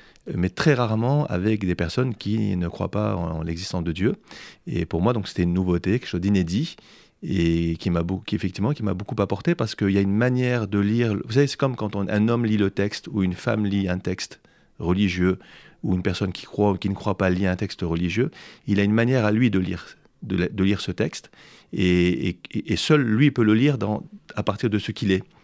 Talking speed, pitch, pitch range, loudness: 245 wpm, 100 Hz, 90-115 Hz, -23 LUFS